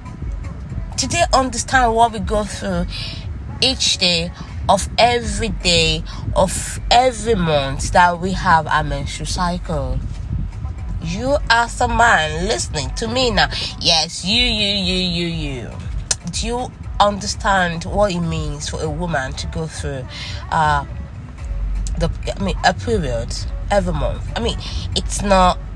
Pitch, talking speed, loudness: 160 Hz, 135 wpm, -18 LUFS